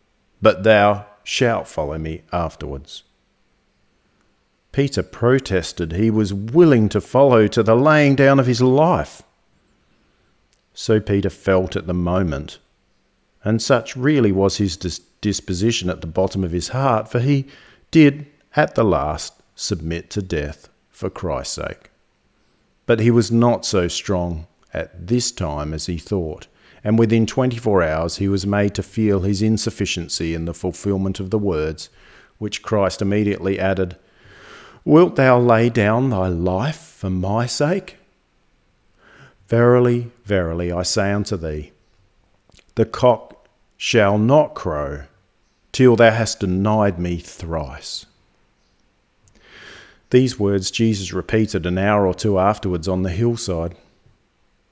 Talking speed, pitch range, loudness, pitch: 135 wpm, 90-115 Hz, -19 LUFS, 100 Hz